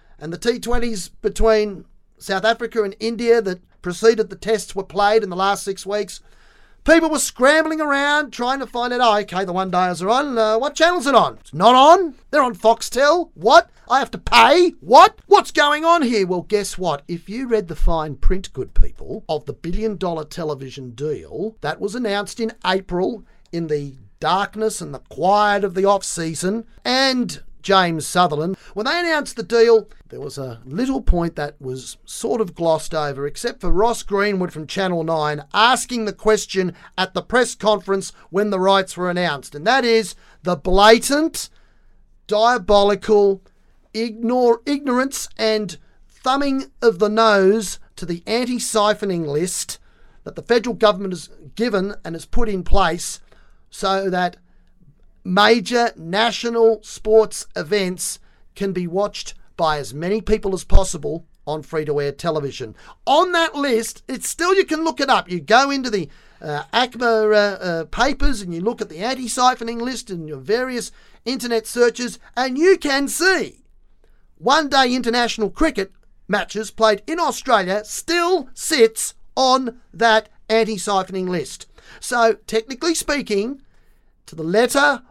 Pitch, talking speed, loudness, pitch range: 215 Hz, 155 wpm, -19 LUFS, 180-240 Hz